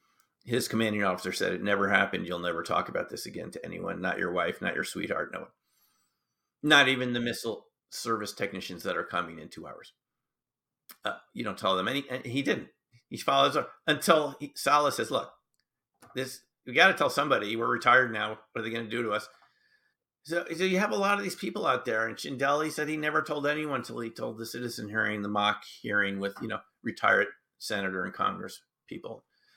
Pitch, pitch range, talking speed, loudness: 120 Hz, 105-150 Hz, 215 wpm, -29 LUFS